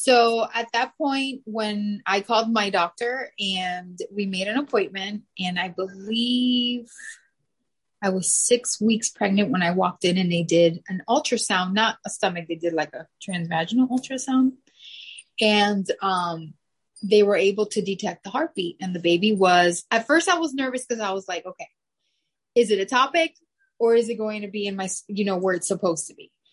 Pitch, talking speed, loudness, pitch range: 205 Hz, 185 wpm, -23 LUFS, 185-240 Hz